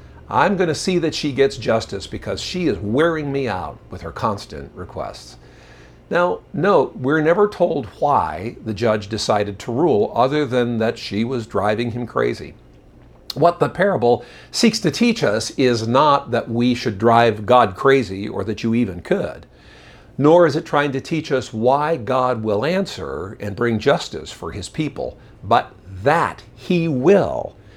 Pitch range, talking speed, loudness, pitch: 105-140 Hz, 170 wpm, -19 LUFS, 120 Hz